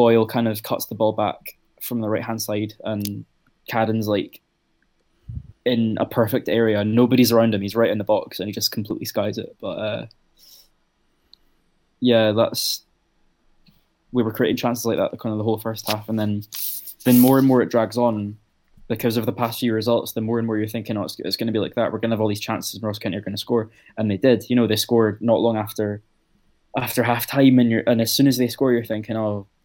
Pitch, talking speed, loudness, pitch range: 115 Hz, 230 wpm, -21 LUFS, 110-120 Hz